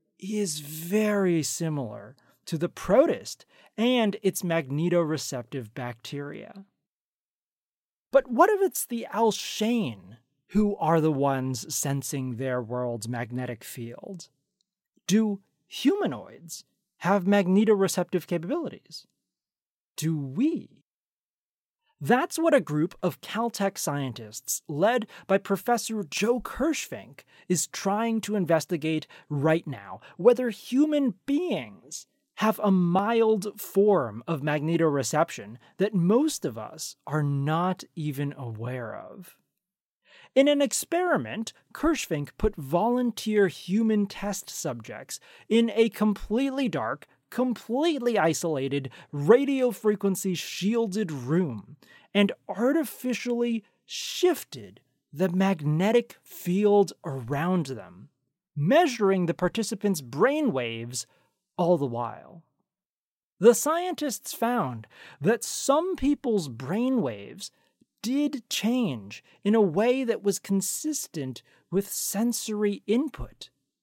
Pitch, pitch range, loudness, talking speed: 195 Hz, 150-230 Hz, -26 LUFS, 100 wpm